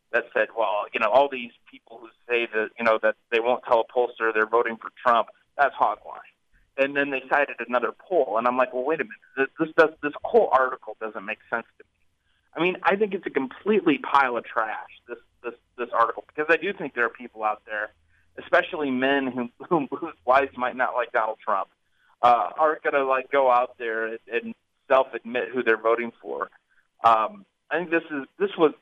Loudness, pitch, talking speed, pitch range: -24 LUFS, 125 Hz, 215 wpm, 115-140 Hz